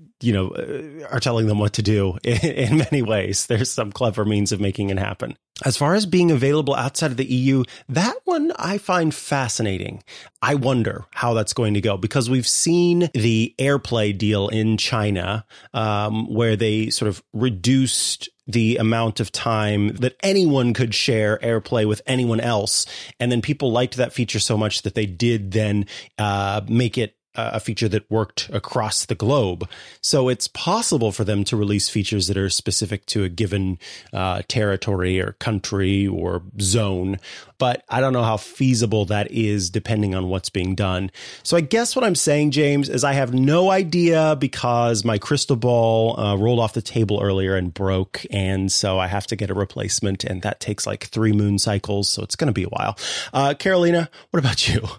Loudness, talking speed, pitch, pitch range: -21 LUFS, 190 wpm, 110 Hz, 105-130 Hz